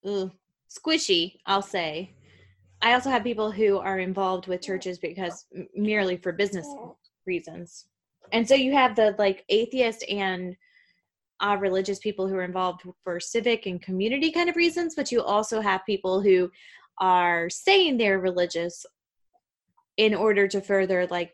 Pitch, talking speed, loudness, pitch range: 195 Hz, 155 wpm, -25 LUFS, 180-230 Hz